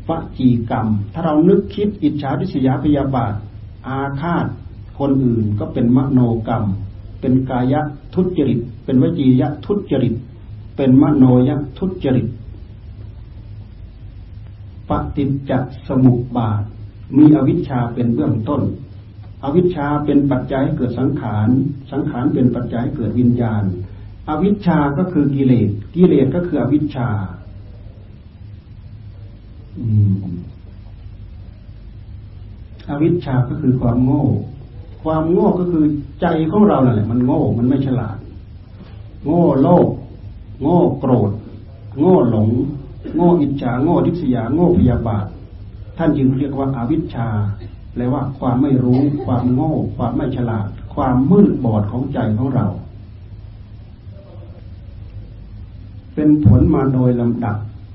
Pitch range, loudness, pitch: 105-140 Hz, -17 LUFS, 120 Hz